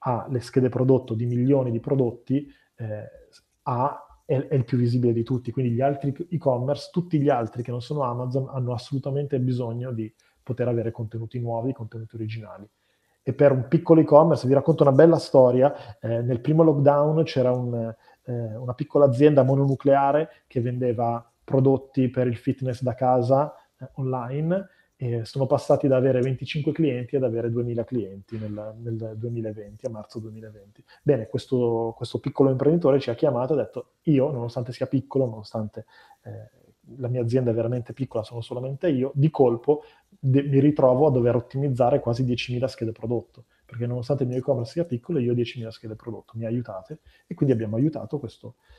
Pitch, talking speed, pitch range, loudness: 125 Hz, 175 wpm, 115-140 Hz, -24 LUFS